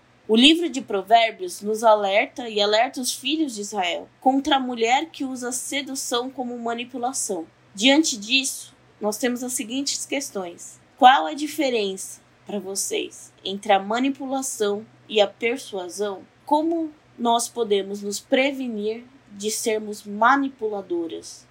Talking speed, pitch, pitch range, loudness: 130 wpm, 235 Hz, 205-270 Hz, -22 LUFS